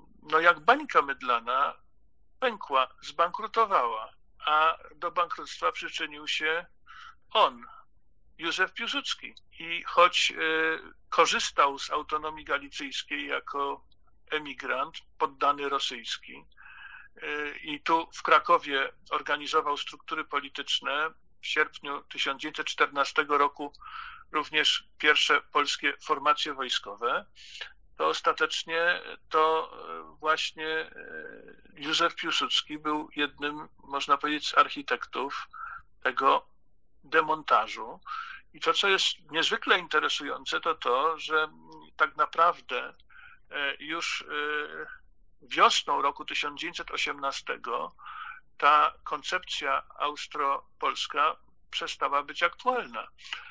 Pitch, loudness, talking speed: 165 Hz, -28 LUFS, 85 wpm